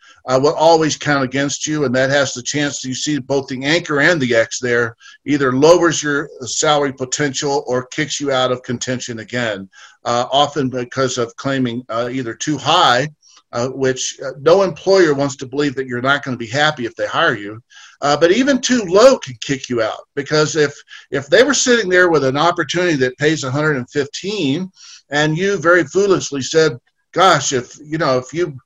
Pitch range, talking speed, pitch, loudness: 130-155 Hz, 195 wpm, 140 Hz, -16 LUFS